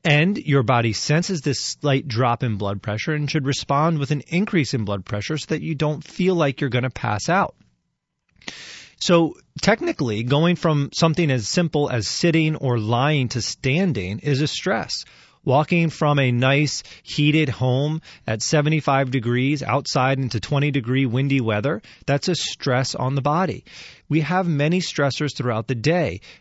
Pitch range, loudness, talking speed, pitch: 125-155 Hz, -21 LUFS, 165 wpm, 140 Hz